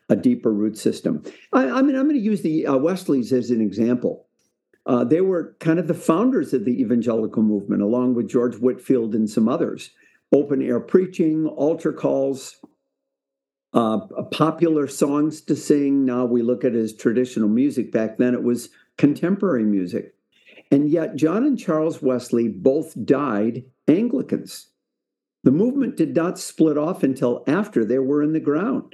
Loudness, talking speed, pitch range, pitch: -21 LUFS, 170 wpm, 120-160 Hz, 135 Hz